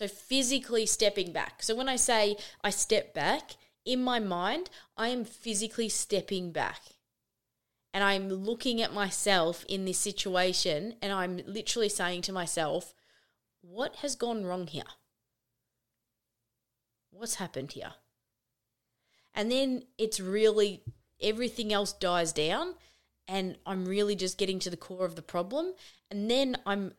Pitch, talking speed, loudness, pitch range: 200 Hz, 140 wpm, -31 LUFS, 180-225 Hz